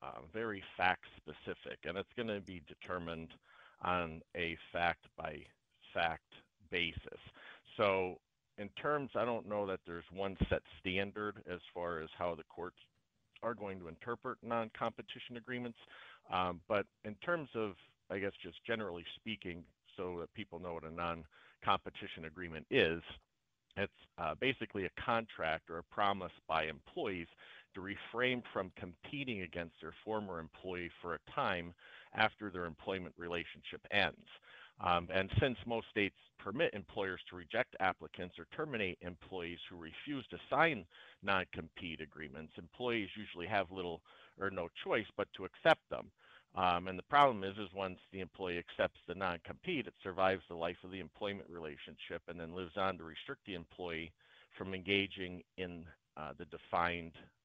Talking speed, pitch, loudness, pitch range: 155 wpm, 90 Hz, -40 LUFS, 85-105 Hz